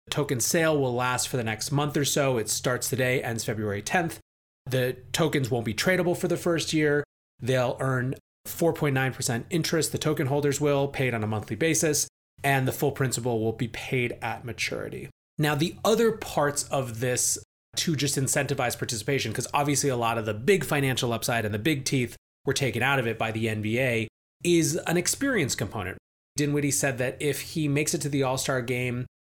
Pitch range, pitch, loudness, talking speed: 120-150 Hz, 135 Hz, -26 LUFS, 190 wpm